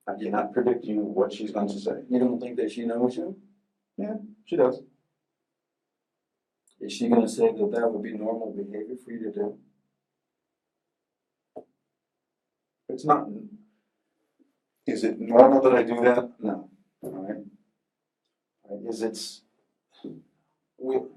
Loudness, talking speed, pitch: -25 LUFS, 140 wpm, 125 Hz